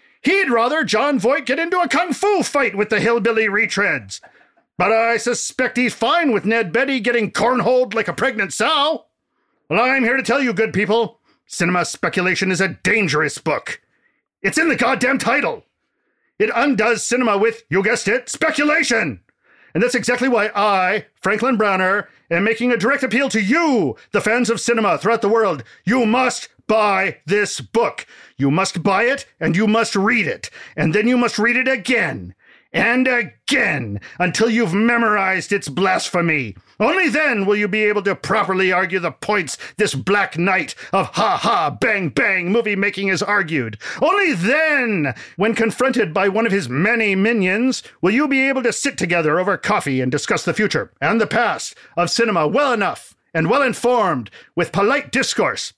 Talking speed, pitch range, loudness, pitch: 175 wpm, 195-245 Hz, -18 LUFS, 225 Hz